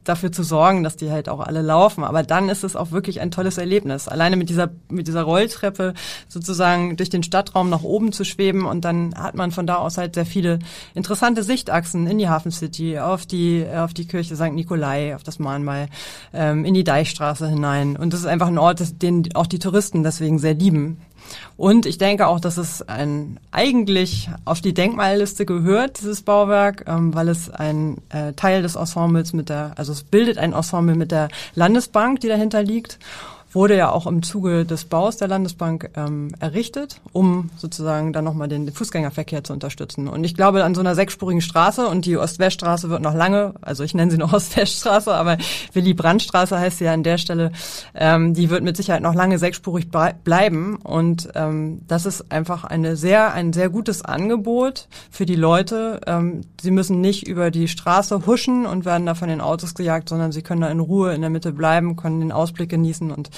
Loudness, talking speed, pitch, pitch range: -20 LUFS, 200 wpm, 170 Hz, 160-190 Hz